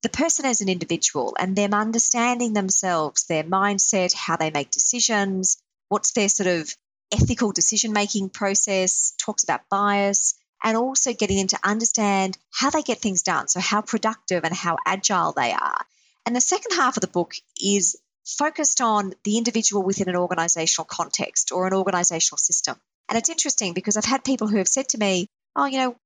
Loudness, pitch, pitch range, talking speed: -21 LUFS, 205 Hz, 185-230 Hz, 185 wpm